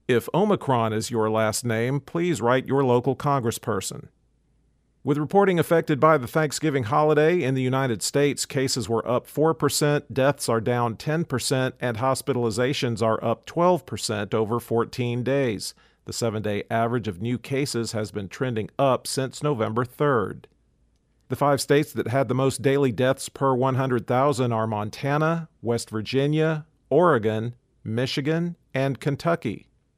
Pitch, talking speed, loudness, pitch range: 130 Hz, 140 wpm, -24 LUFS, 115-145 Hz